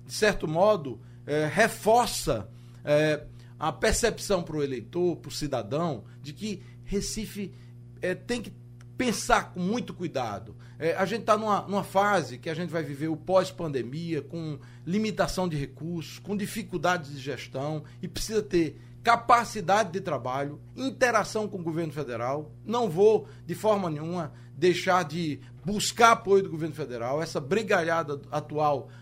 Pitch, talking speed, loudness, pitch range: 165 Hz, 150 wpm, -28 LUFS, 135-195 Hz